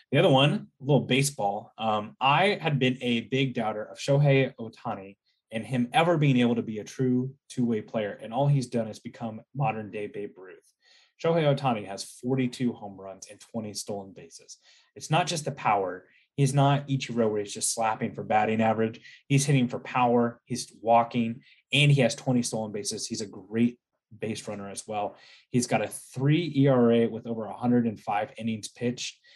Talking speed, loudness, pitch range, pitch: 190 wpm, -27 LUFS, 110-135 Hz, 120 Hz